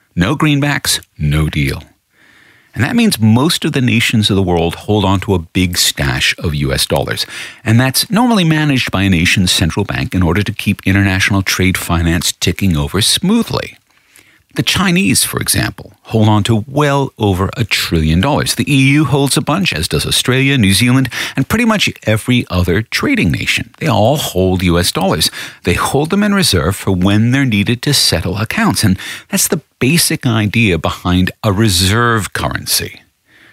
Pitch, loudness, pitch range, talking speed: 110 Hz, -13 LUFS, 95-135 Hz, 175 wpm